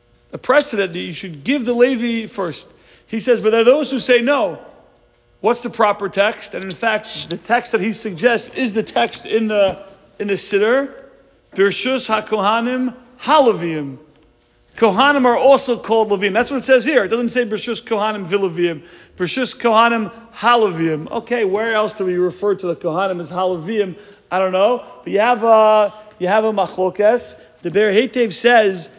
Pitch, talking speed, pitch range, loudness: 215 Hz, 170 wpm, 190-240 Hz, -17 LUFS